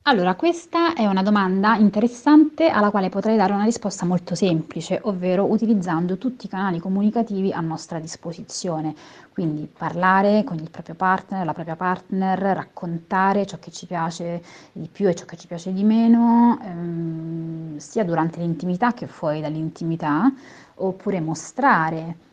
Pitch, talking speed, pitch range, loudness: 185 Hz, 150 wpm, 165-210 Hz, -21 LUFS